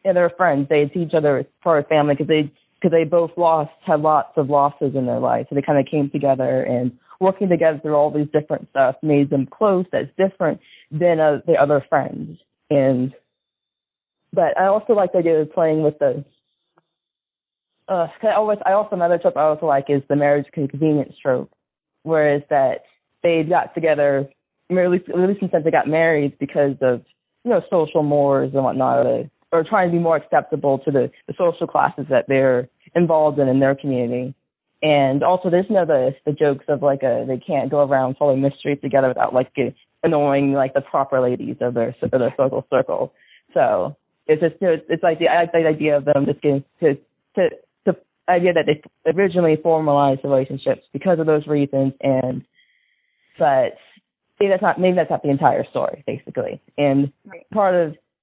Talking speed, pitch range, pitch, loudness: 195 wpm, 140-170 Hz, 150 Hz, -19 LUFS